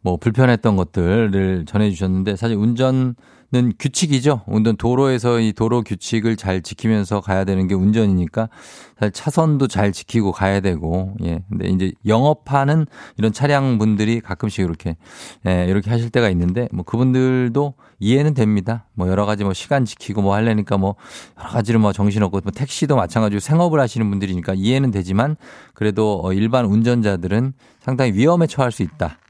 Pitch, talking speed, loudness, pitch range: 110 Hz, 370 characters per minute, -18 LUFS, 100-125 Hz